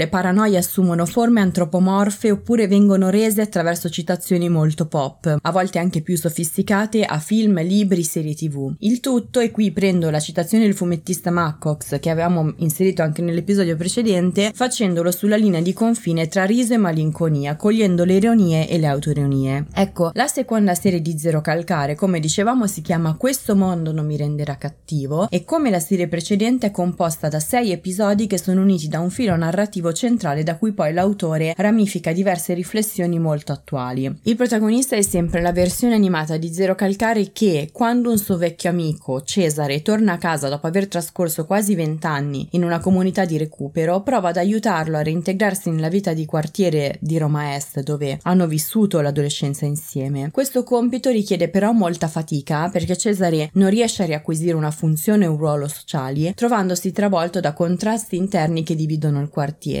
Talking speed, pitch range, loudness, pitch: 170 wpm, 160-200 Hz, -19 LUFS, 175 Hz